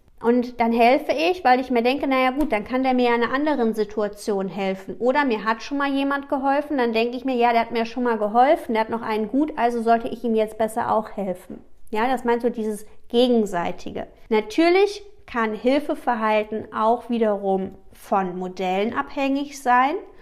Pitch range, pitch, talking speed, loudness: 220-265 Hz, 235 Hz, 195 wpm, -22 LUFS